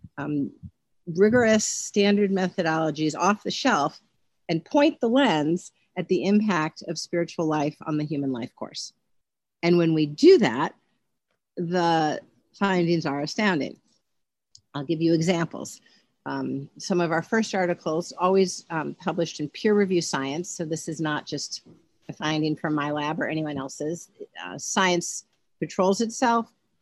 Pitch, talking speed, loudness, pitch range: 170 Hz, 145 wpm, -25 LUFS, 155-190 Hz